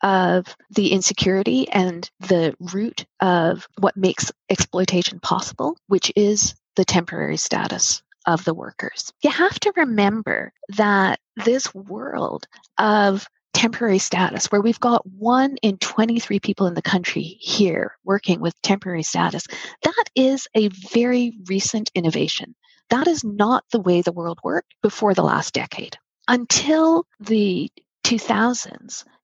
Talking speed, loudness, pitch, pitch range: 135 wpm, -20 LUFS, 205 Hz, 185-235 Hz